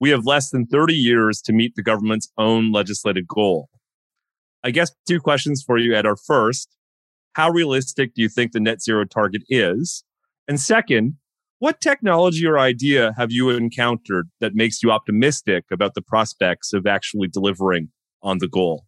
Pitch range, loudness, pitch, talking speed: 105-145 Hz, -19 LUFS, 120 Hz, 170 wpm